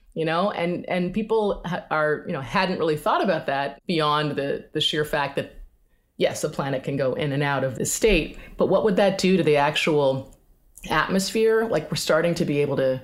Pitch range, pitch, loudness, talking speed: 145-185 Hz, 155 Hz, -23 LUFS, 210 wpm